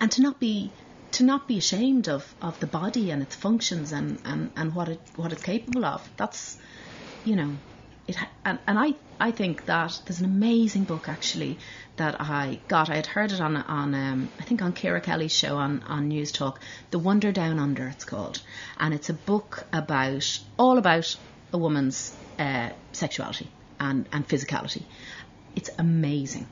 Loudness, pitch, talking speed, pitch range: -27 LUFS, 160 Hz, 185 wpm, 145-205 Hz